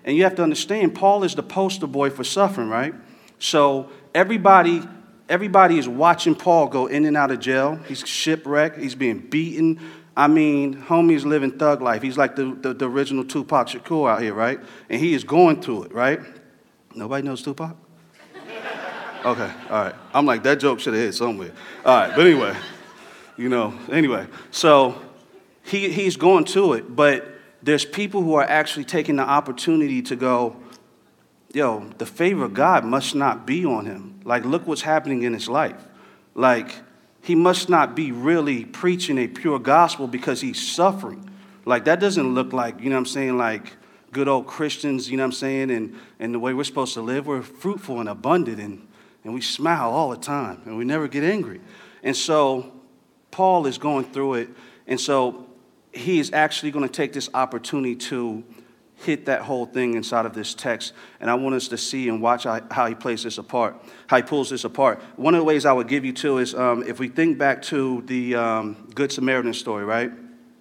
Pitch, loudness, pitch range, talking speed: 135 Hz, -21 LUFS, 125-160 Hz, 195 wpm